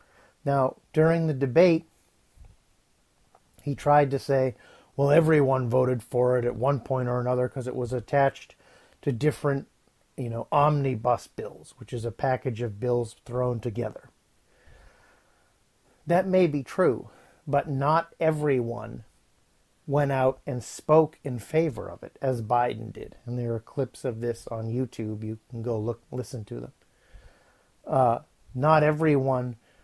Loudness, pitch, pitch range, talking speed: -26 LUFS, 130 Hz, 120-145 Hz, 145 wpm